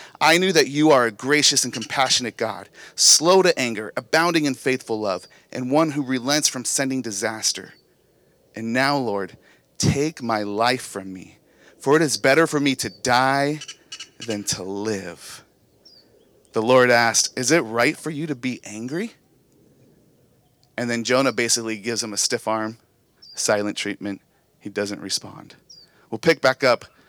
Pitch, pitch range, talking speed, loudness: 125 Hz, 110-145 Hz, 160 wpm, -20 LUFS